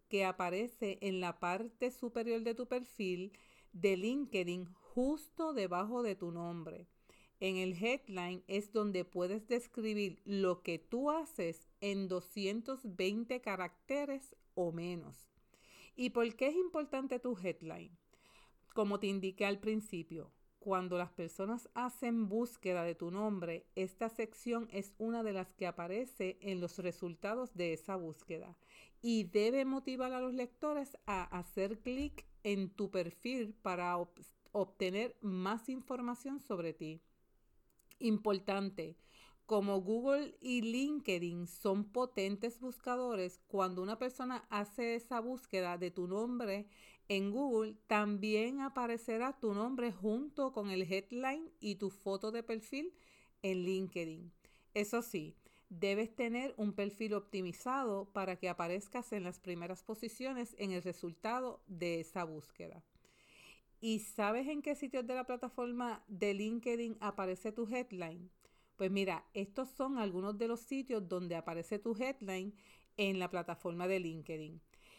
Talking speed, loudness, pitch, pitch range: 135 wpm, -40 LUFS, 205 Hz, 185-240 Hz